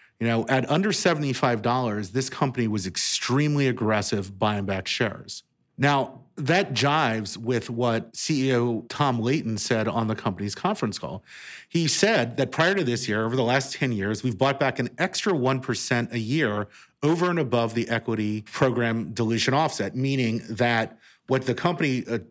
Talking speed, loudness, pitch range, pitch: 170 wpm, -25 LUFS, 115-135 Hz, 120 Hz